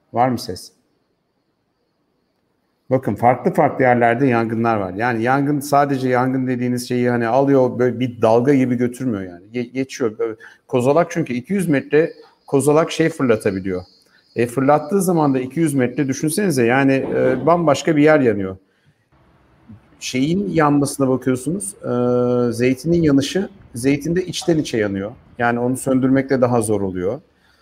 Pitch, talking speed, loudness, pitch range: 130 Hz, 135 wpm, -18 LUFS, 120-145 Hz